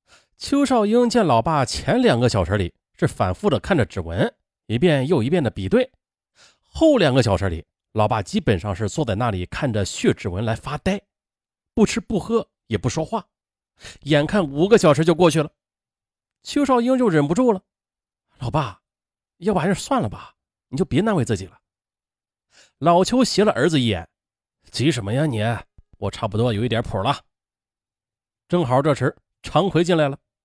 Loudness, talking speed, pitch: -21 LUFS, 250 characters per minute, 140 Hz